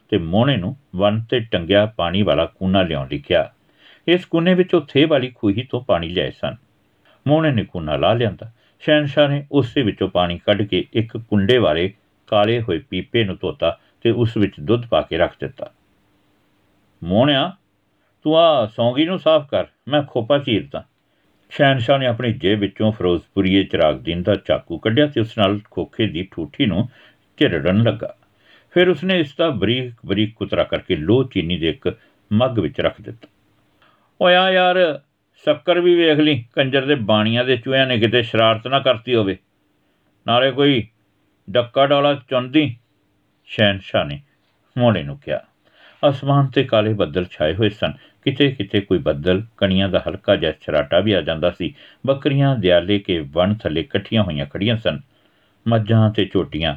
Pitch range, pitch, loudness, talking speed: 100-140 Hz, 115 Hz, -18 LUFS, 160 wpm